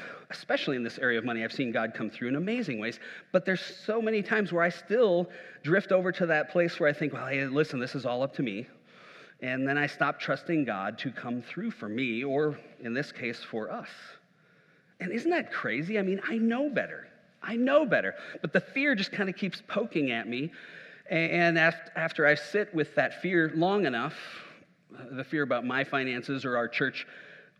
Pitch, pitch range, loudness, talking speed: 170 Hz, 140-195 Hz, -29 LUFS, 205 wpm